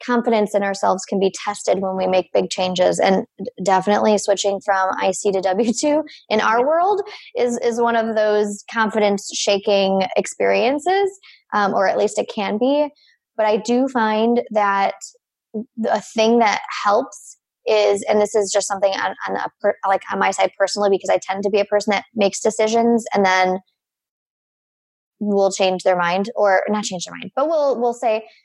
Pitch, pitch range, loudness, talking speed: 210 Hz, 195-235 Hz, -19 LUFS, 175 wpm